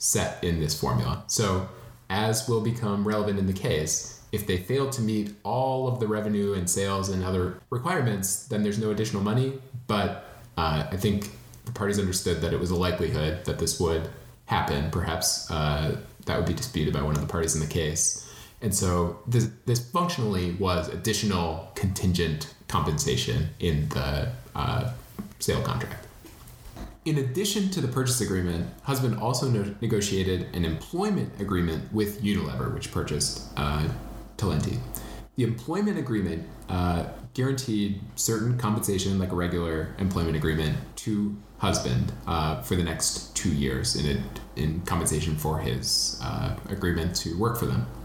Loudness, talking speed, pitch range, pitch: -27 LUFS, 155 wpm, 85-115 Hz, 100 Hz